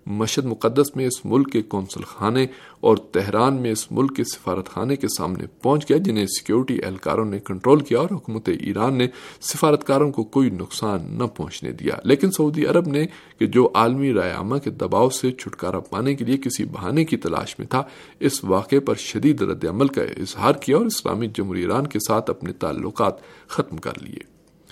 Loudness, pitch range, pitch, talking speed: -22 LUFS, 110-140 Hz, 125 Hz, 190 wpm